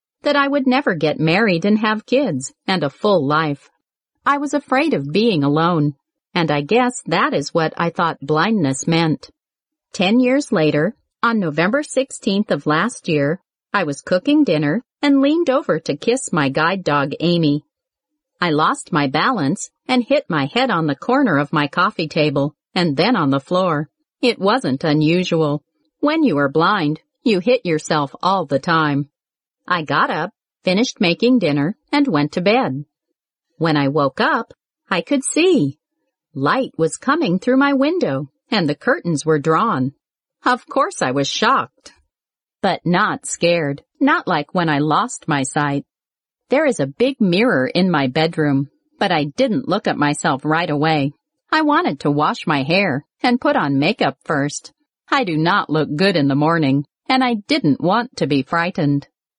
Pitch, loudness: 170 Hz, -18 LUFS